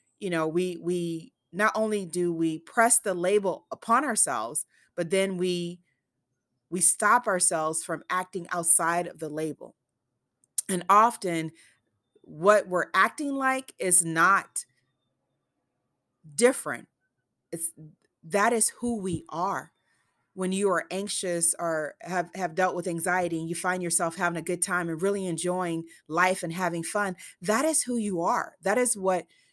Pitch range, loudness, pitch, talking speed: 165-195 Hz, -26 LUFS, 180 Hz, 150 wpm